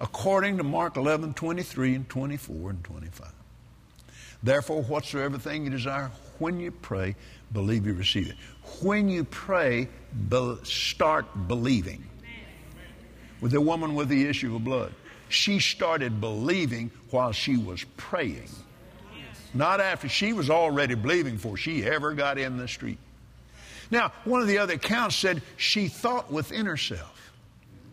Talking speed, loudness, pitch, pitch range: 150 wpm, -27 LUFS, 135 Hz, 115-165 Hz